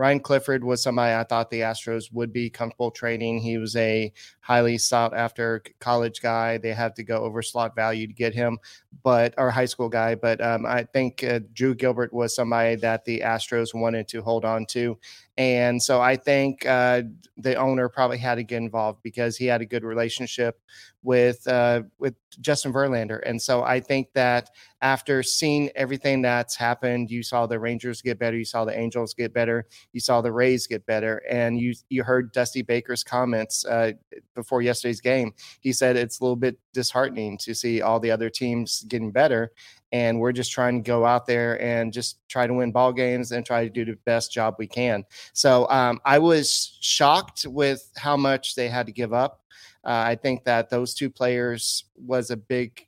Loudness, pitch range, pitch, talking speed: -24 LUFS, 115-125 Hz, 120 Hz, 200 wpm